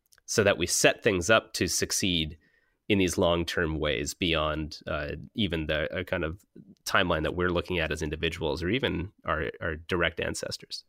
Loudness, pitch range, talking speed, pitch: -28 LUFS, 80-90 Hz, 180 wpm, 85 Hz